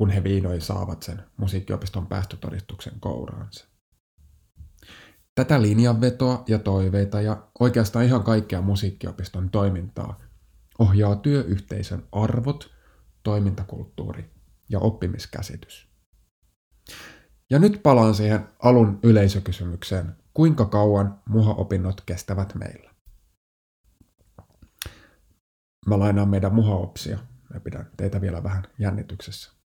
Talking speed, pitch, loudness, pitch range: 90 wpm, 100 Hz, -23 LUFS, 90-110 Hz